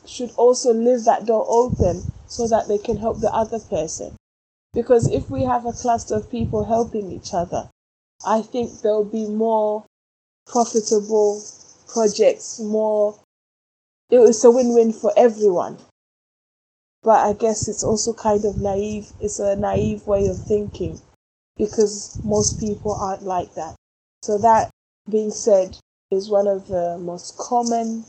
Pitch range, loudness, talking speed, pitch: 205-230 Hz, -20 LUFS, 145 wpm, 215 Hz